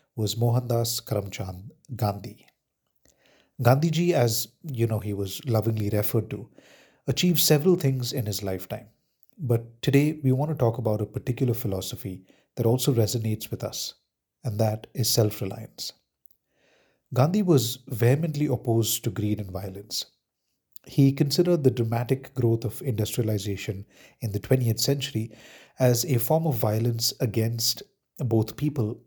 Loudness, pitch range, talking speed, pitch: -25 LUFS, 110-135 Hz, 135 wpm, 115 Hz